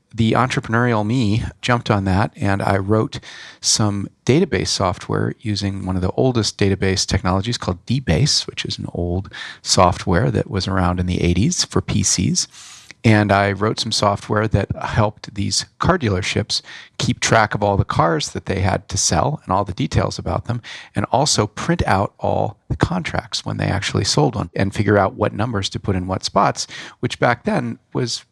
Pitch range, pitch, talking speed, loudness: 95-115 Hz, 105 Hz, 185 wpm, -19 LUFS